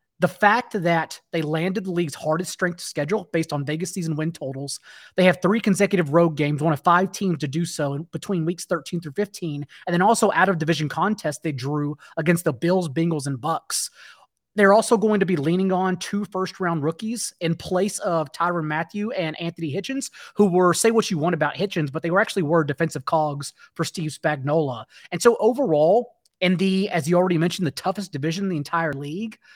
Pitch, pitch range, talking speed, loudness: 175 Hz, 160-195 Hz, 205 wpm, -23 LUFS